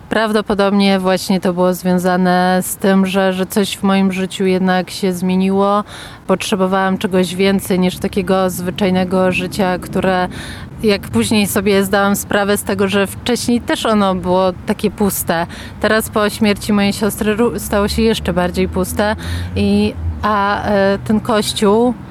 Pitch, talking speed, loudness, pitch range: 195 Hz, 145 wpm, -15 LUFS, 185-210 Hz